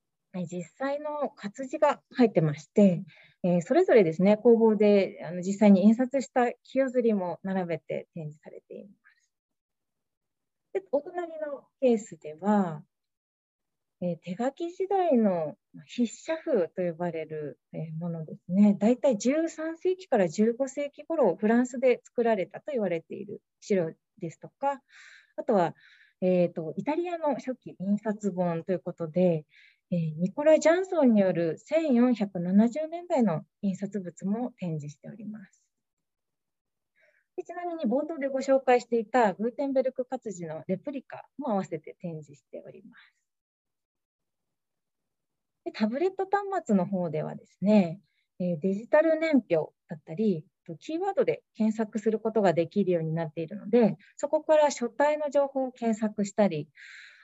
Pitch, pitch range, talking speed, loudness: 215 Hz, 175-275 Hz, 280 characters per minute, -27 LUFS